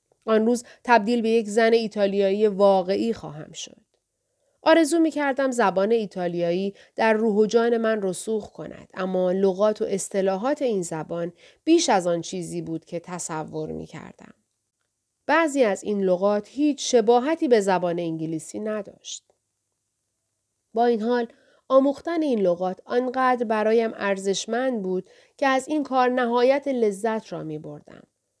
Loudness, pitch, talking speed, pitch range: -23 LUFS, 215 Hz, 140 wpm, 180-250 Hz